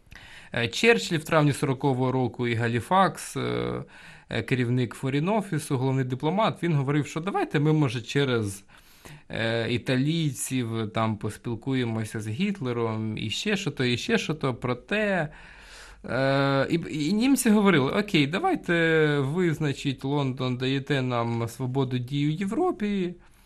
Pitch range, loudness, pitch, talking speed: 120-160 Hz, -26 LUFS, 135 Hz, 120 wpm